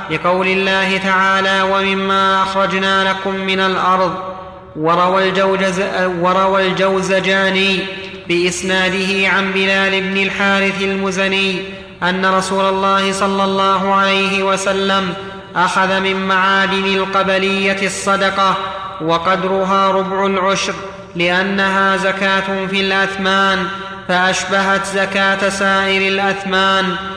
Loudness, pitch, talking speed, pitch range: -14 LUFS, 195 Hz, 90 wpm, 190-195 Hz